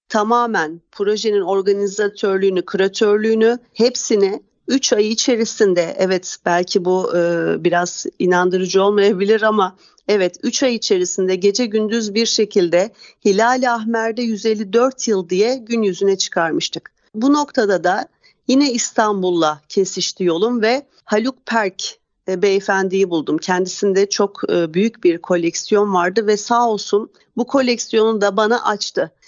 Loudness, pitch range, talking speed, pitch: -17 LUFS, 190-230 Hz, 125 wpm, 205 Hz